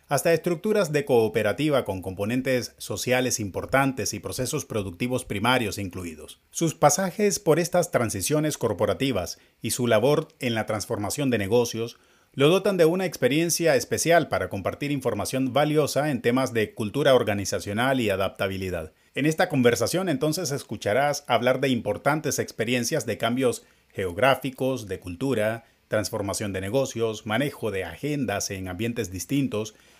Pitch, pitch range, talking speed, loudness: 125 Hz, 110-145 Hz, 135 wpm, -25 LUFS